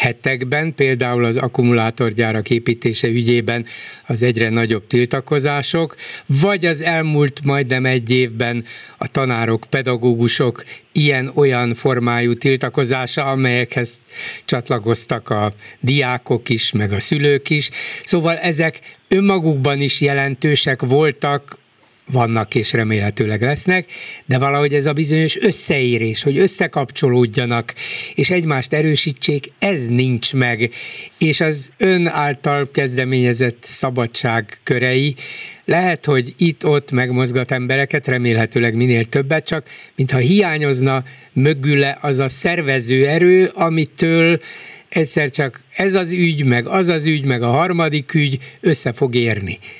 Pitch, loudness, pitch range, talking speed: 135 Hz, -16 LUFS, 120-155 Hz, 115 wpm